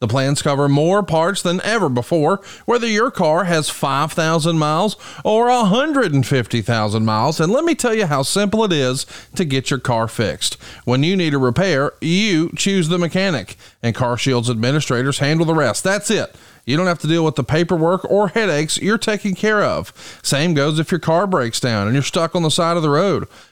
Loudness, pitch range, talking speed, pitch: -17 LUFS, 135-190 Hz, 200 wpm, 160 Hz